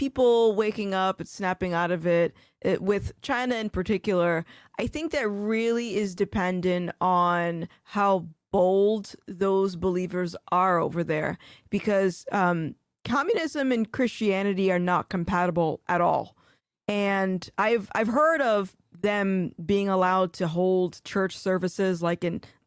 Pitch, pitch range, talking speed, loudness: 190 Hz, 175-205 Hz, 135 wpm, -26 LUFS